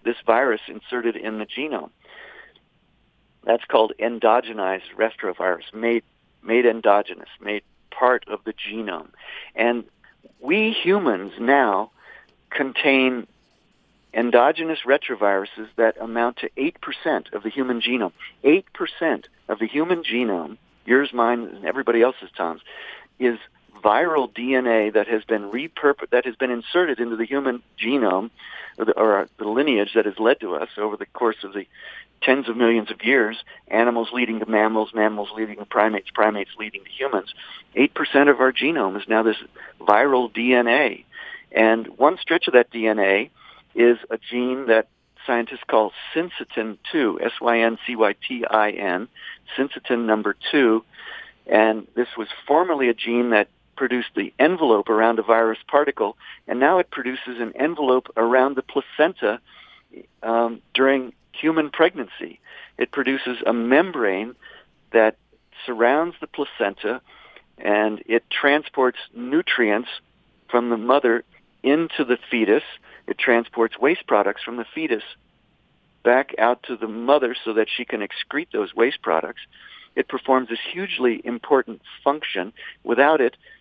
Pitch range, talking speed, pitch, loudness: 110-130 Hz, 140 wpm, 120 Hz, -21 LUFS